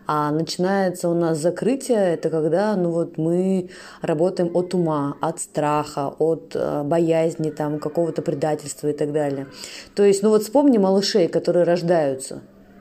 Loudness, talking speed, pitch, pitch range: -21 LUFS, 145 wpm, 165 Hz, 155-180 Hz